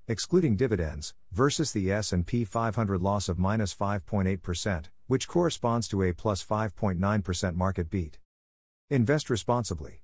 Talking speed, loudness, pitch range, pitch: 120 wpm, -29 LUFS, 90-115 Hz, 100 Hz